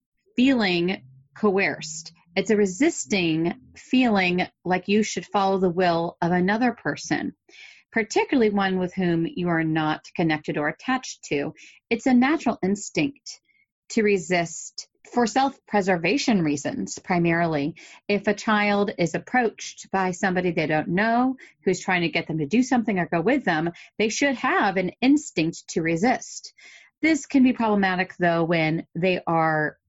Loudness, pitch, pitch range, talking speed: -23 LUFS, 195 Hz, 170-245 Hz, 150 wpm